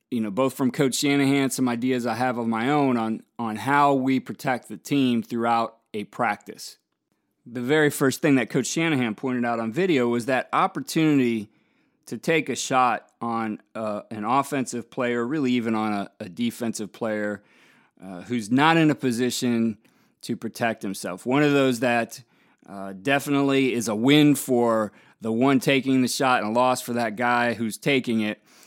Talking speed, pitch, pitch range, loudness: 180 wpm, 120 Hz, 115-135 Hz, -23 LUFS